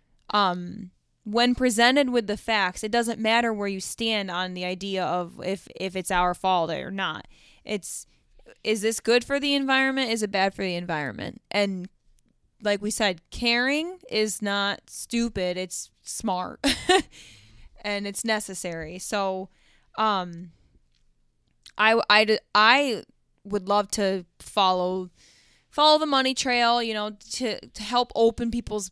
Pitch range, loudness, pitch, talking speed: 185-235 Hz, -24 LUFS, 205 Hz, 145 wpm